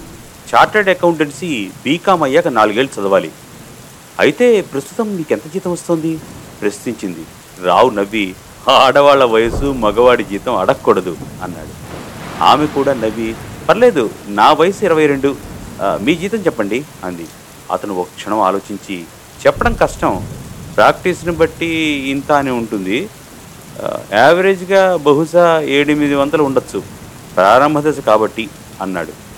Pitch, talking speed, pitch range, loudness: 140 Hz, 105 wpm, 110-160 Hz, -14 LUFS